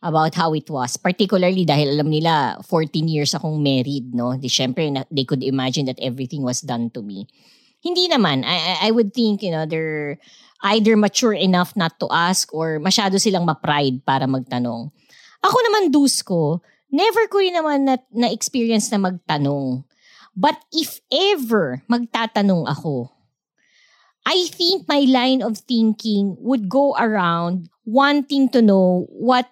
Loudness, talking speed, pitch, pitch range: -19 LUFS, 150 wpm, 180 Hz, 145-240 Hz